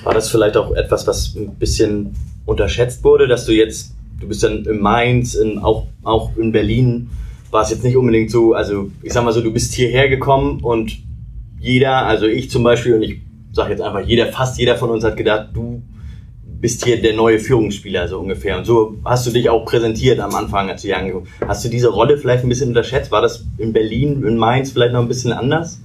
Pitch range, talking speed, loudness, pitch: 110-125 Hz, 220 wpm, -16 LUFS, 115 Hz